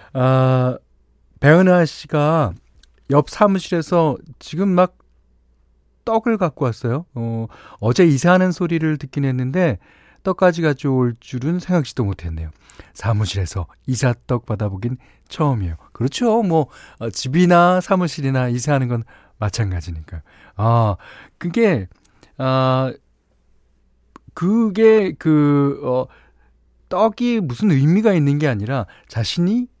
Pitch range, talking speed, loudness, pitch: 105-175 Hz, 235 characters per minute, -18 LUFS, 130 Hz